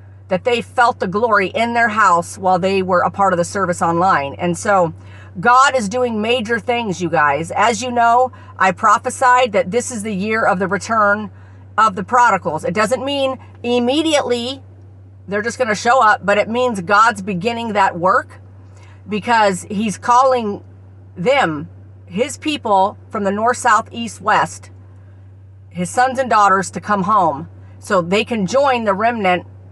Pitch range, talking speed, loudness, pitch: 170-240 Hz, 170 wpm, -16 LUFS, 205 Hz